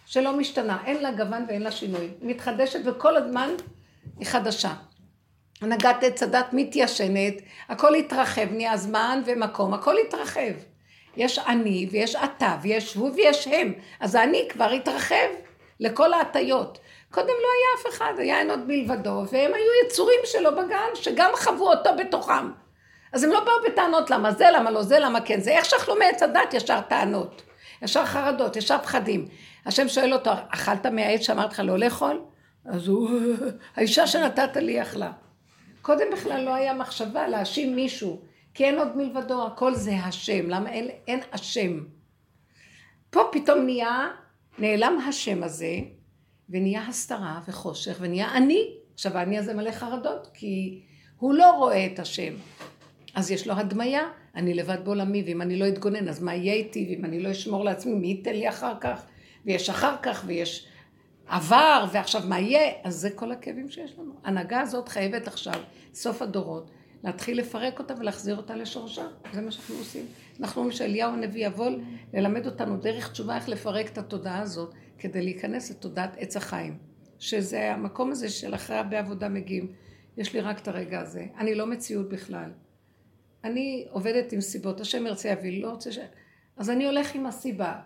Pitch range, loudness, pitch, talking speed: 195-265 Hz, -25 LUFS, 225 Hz, 165 wpm